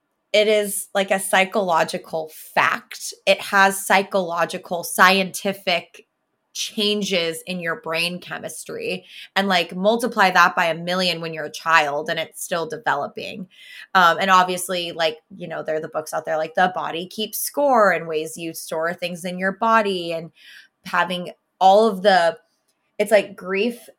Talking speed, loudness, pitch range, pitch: 155 wpm, -20 LUFS, 165-200 Hz, 185 Hz